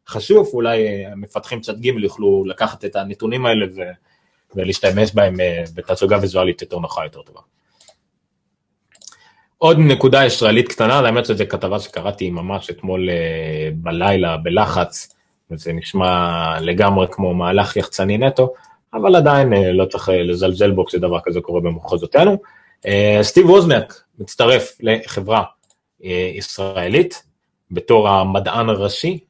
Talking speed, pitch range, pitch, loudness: 115 wpm, 90-120 Hz, 100 Hz, -16 LUFS